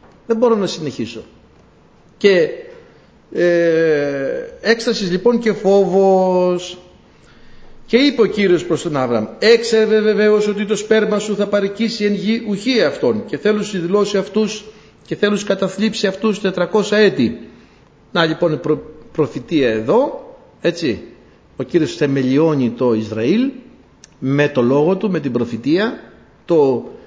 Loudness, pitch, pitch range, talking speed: -16 LUFS, 200 Hz, 165-220 Hz, 135 wpm